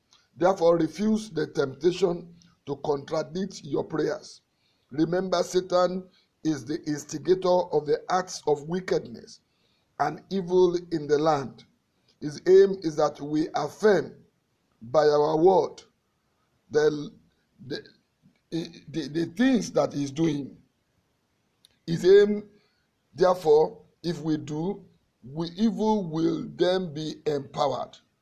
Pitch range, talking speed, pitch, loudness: 150-190 Hz, 115 wpm, 170 Hz, -26 LUFS